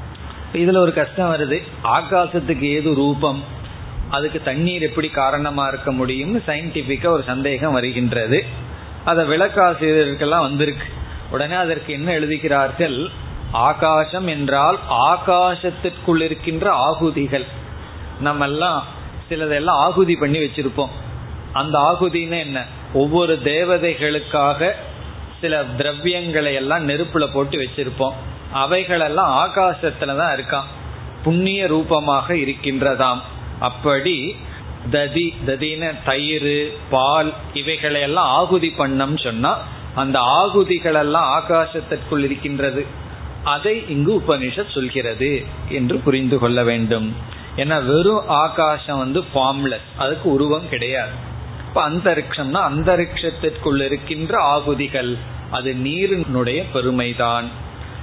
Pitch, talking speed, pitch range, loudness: 145 Hz, 90 wpm, 135-165 Hz, -19 LUFS